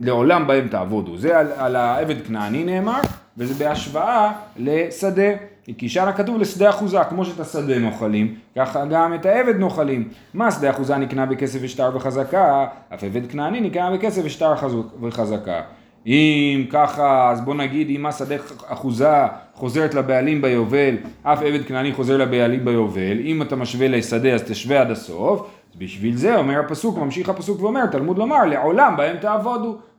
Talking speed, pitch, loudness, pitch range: 155 wpm, 140 Hz, -20 LUFS, 125-180 Hz